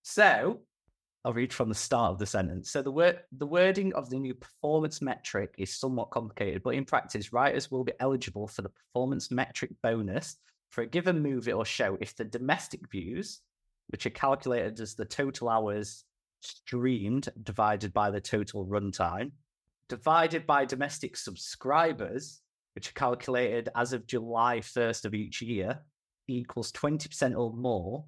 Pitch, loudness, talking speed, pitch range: 125 Hz, -31 LUFS, 160 wpm, 110-135 Hz